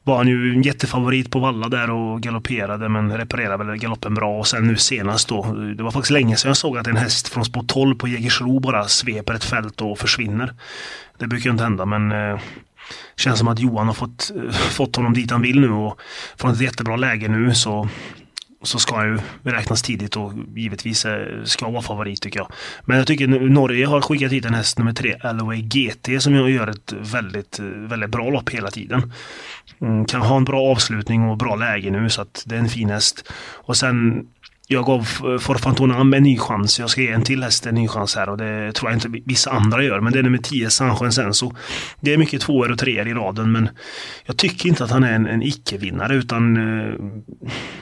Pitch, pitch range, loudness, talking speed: 115 Hz, 110-130 Hz, -19 LUFS, 220 wpm